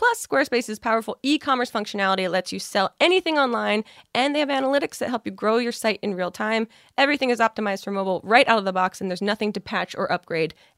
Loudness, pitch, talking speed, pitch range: -23 LUFS, 220 Hz, 235 wpm, 195-265 Hz